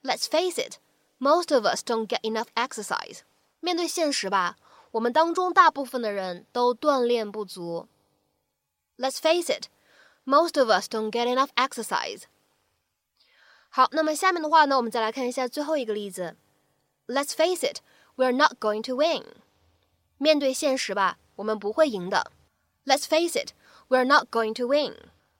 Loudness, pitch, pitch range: -25 LUFS, 260 Hz, 220-310 Hz